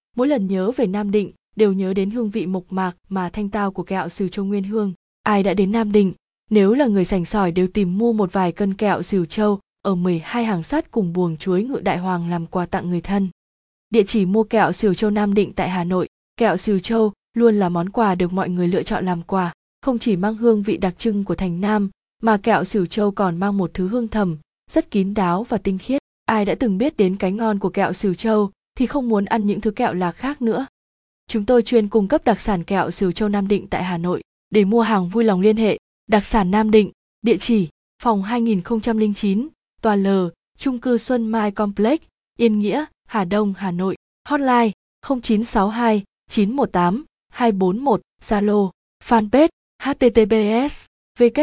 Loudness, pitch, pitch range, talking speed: -20 LUFS, 210 Hz, 190-225 Hz, 210 wpm